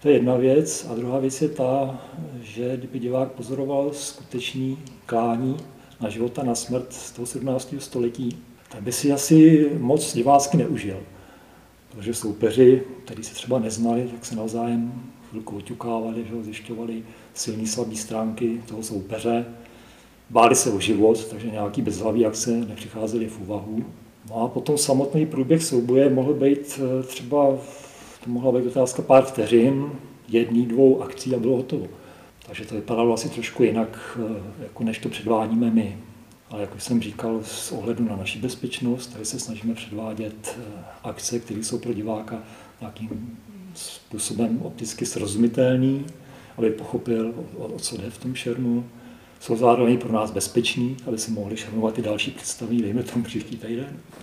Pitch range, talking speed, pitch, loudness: 110-130 Hz, 155 wpm, 120 Hz, -23 LUFS